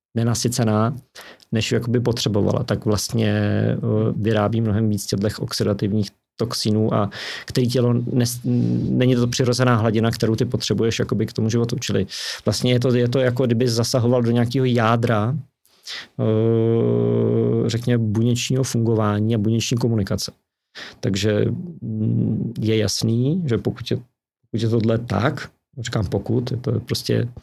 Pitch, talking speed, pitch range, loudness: 115 Hz, 135 wpm, 110-125 Hz, -21 LUFS